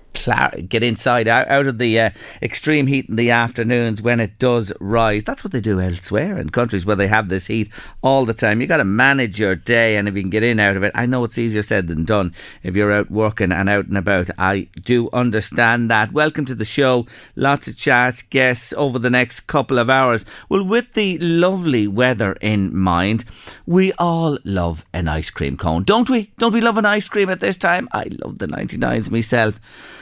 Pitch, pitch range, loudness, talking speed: 115 Hz, 100-130 Hz, -17 LUFS, 215 wpm